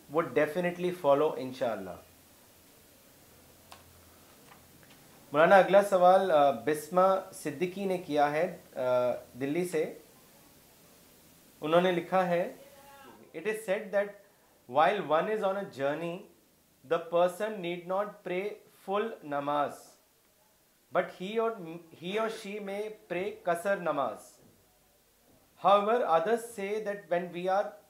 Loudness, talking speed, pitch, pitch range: -30 LUFS, 110 wpm, 185 Hz, 165-205 Hz